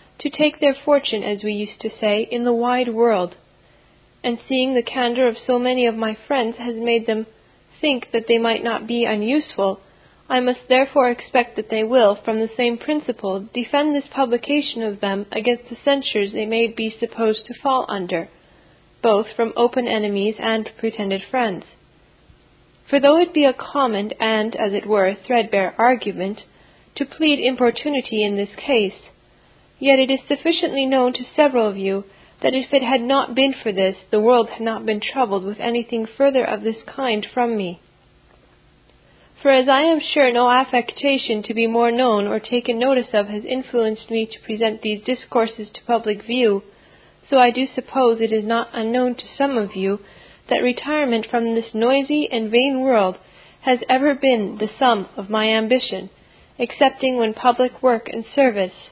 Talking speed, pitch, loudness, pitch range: 175 wpm, 235 Hz, -19 LUFS, 220-260 Hz